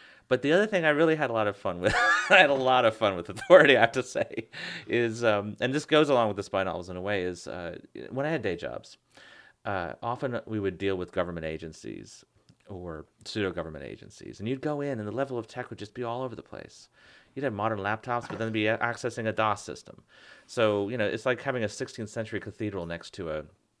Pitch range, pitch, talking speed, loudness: 100-125 Hz, 110 Hz, 240 wpm, -27 LUFS